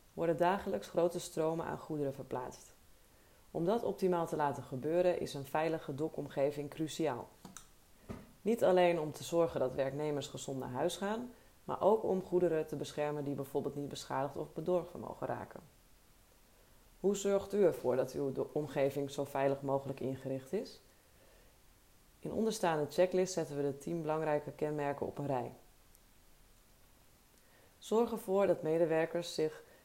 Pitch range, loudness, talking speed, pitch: 140-175 Hz, -36 LUFS, 145 wpm, 155 Hz